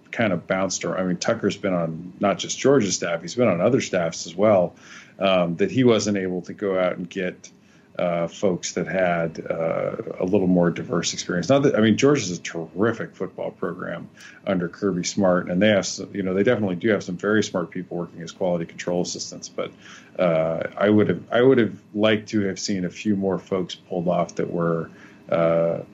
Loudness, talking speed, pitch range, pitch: -23 LUFS, 210 wpm, 85-105 Hz, 90 Hz